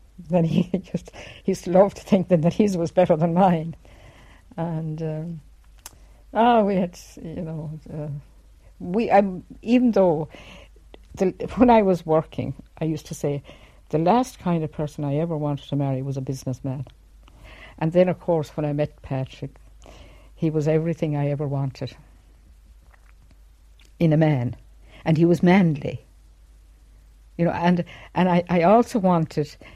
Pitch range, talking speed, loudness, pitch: 130-175 Hz, 160 wpm, -22 LUFS, 155 Hz